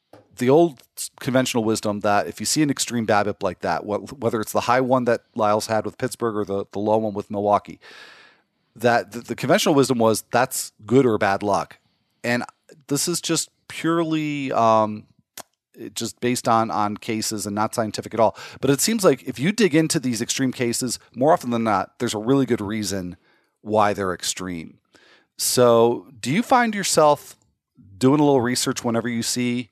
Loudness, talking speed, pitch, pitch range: -21 LUFS, 190 wpm, 120 Hz, 105-135 Hz